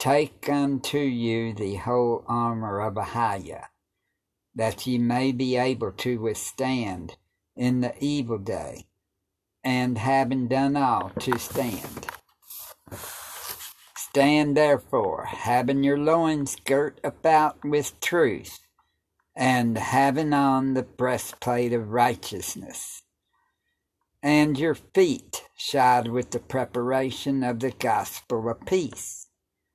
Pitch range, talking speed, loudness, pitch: 115-140 Hz, 105 wpm, -25 LUFS, 125 Hz